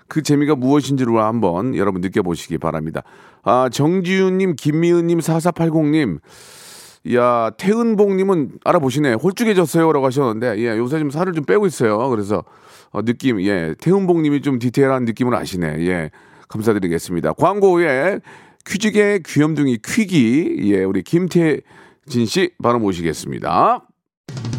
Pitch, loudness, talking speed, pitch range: 140 Hz, -17 LUFS, 320 characters per minute, 110-175 Hz